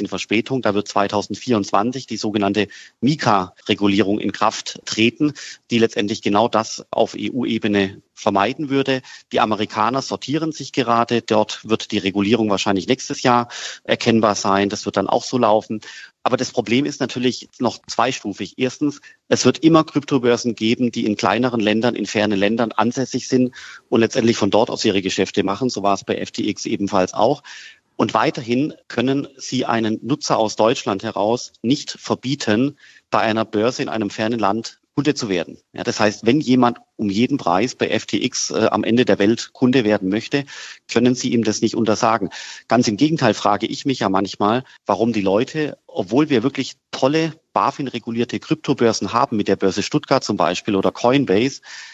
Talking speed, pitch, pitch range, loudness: 170 wpm, 115 Hz, 105-130 Hz, -19 LUFS